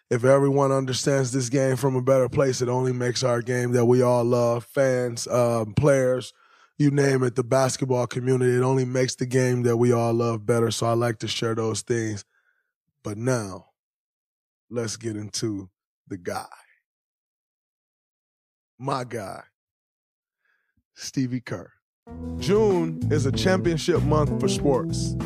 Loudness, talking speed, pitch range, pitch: -23 LUFS, 145 wpm, 115-130 Hz, 125 Hz